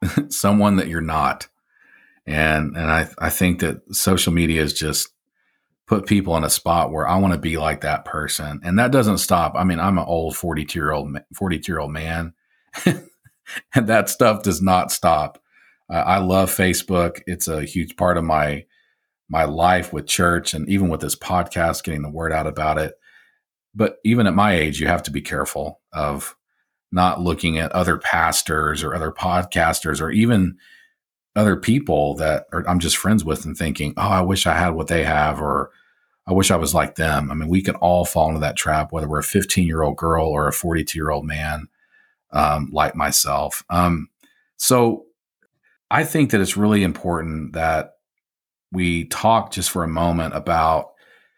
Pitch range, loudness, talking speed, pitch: 80-95 Hz, -20 LUFS, 185 wpm, 85 Hz